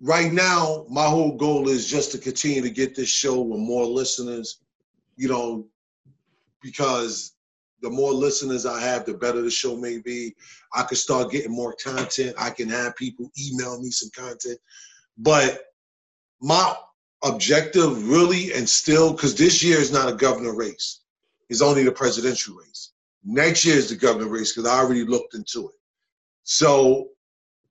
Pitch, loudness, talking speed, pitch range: 130 Hz, -21 LUFS, 165 wpm, 120-150 Hz